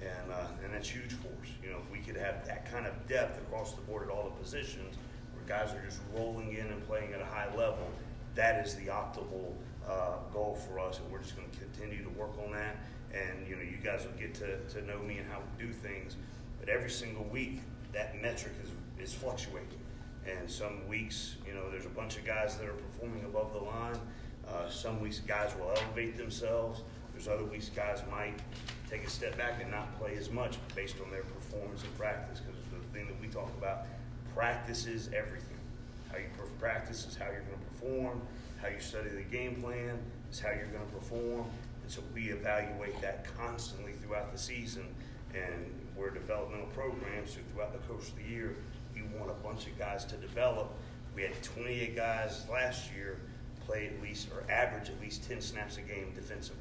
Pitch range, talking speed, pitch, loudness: 105-120 Hz, 210 wpm, 110 Hz, -40 LUFS